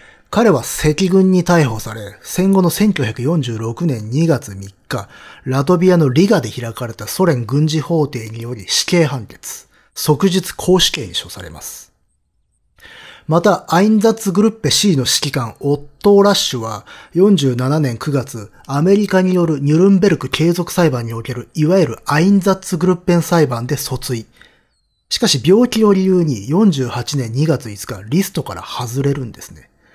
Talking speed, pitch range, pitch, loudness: 290 characters per minute, 120-185 Hz, 150 Hz, -15 LUFS